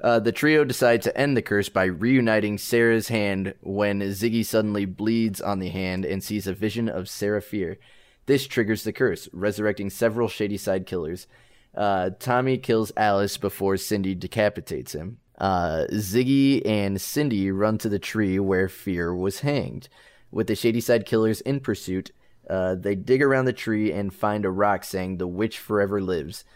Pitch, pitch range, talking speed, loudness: 105 Hz, 95-115 Hz, 170 wpm, -24 LUFS